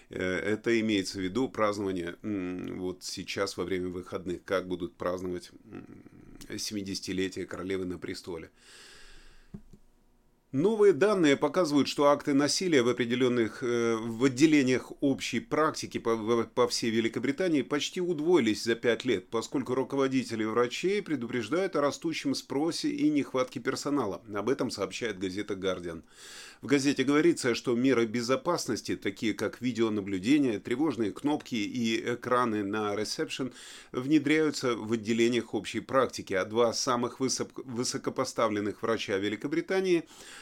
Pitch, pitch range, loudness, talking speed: 120 Hz, 105-145 Hz, -29 LUFS, 120 wpm